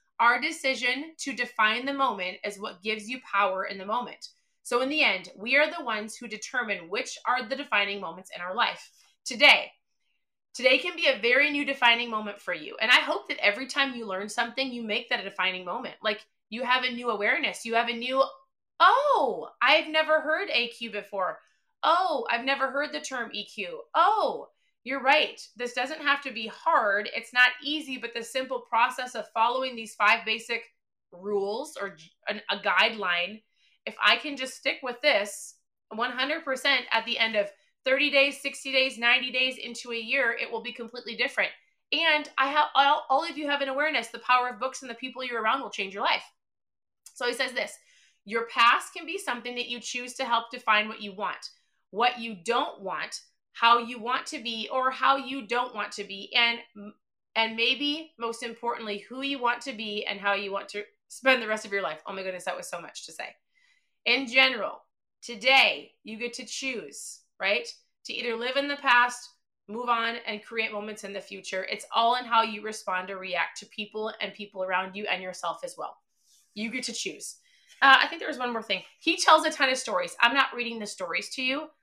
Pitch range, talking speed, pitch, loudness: 215-270 Hz, 210 wpm, 240 Hz, -26 LUFS